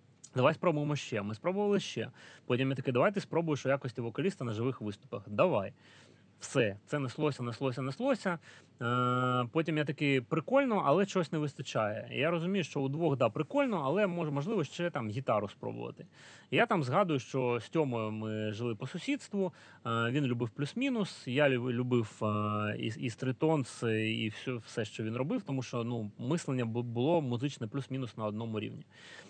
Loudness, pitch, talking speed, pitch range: -33 LUFS, 130 Hz, 160 wpm, 120-160 Hz